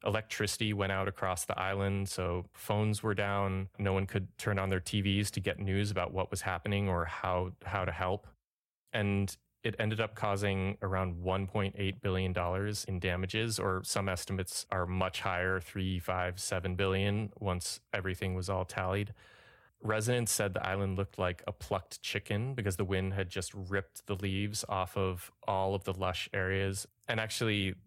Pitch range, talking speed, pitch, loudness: 95-105 Hz, 170 wpm, 95 Hz, -34 LUFS